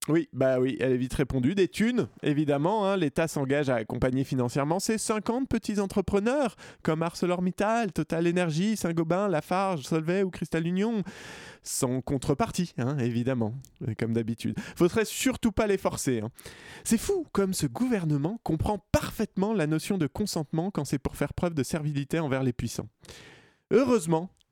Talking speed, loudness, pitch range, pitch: 155 wpm, -28 LUFS, 140-205 Hz, 170 Hz